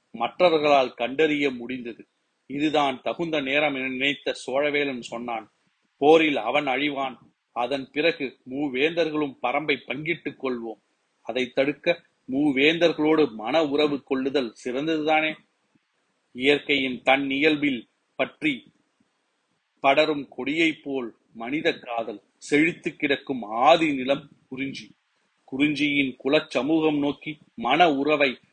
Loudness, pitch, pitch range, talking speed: -24 LUFS, 145 Hz, 135-155 Hz, 95 wpm